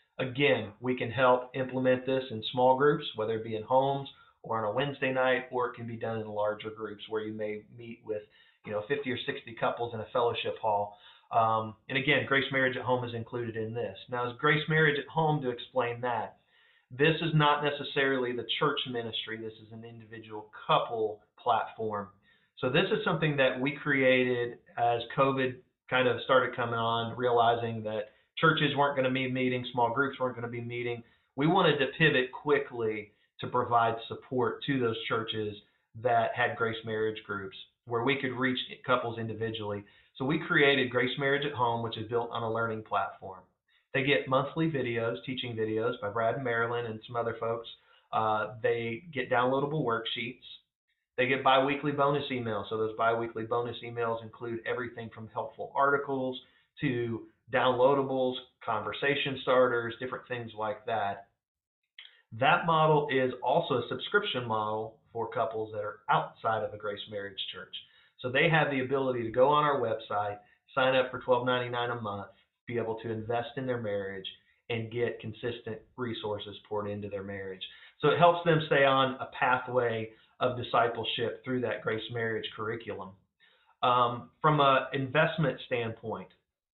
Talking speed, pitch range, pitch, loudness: 175 wpm, 110-130 Hz, 120 Hz, -30 LUFS